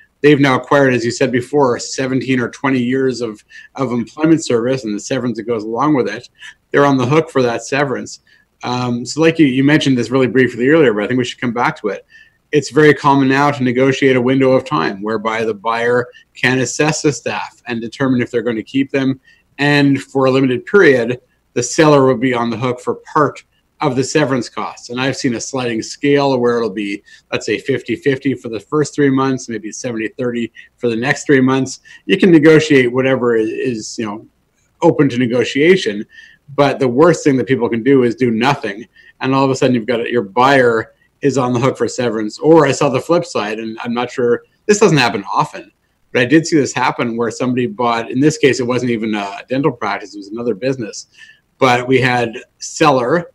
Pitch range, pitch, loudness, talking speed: 120-145 Hz, 130 Hz, -15 LUFS, 215 wpm